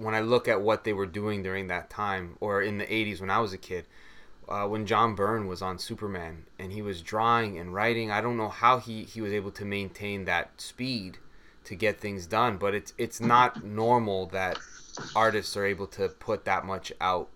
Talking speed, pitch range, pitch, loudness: 220 wpm, 95-110 Hz, 105 Hz, -29 LUFS